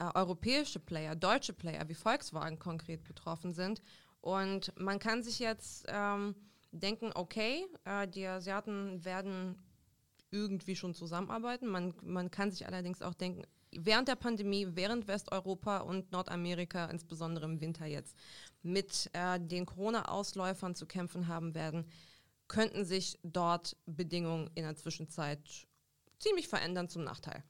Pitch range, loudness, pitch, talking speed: 170-200 Hz, -38 LUFS, 185 Hz, 135 wpm